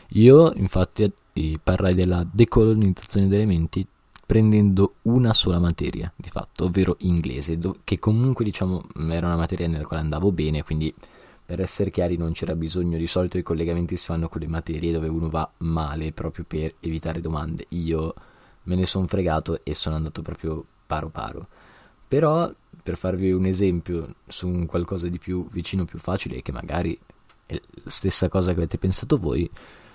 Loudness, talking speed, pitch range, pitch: -23 LUFS, 165 wpm, 80-95 Hz, 90 Hz